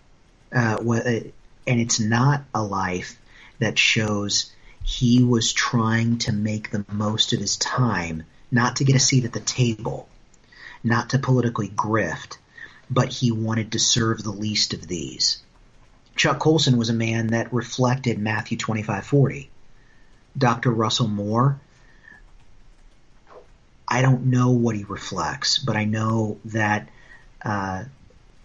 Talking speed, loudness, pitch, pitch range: 130 wpm, -22 LUFS, 115 Hz, 105-125 Hz